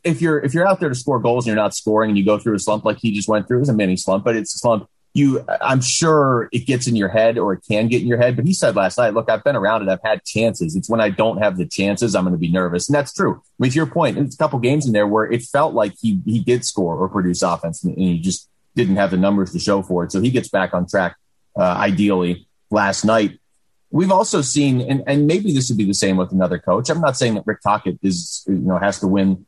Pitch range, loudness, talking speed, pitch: 95-125 Hz, -18 LUFS, 290 wpm, 110 Hz